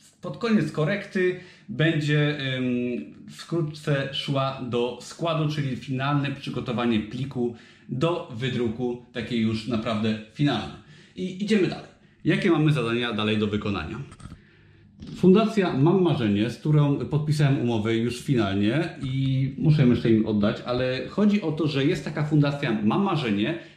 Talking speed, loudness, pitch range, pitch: 130 wpm, -25 LUFS, 120-160 Hz, 135 Hz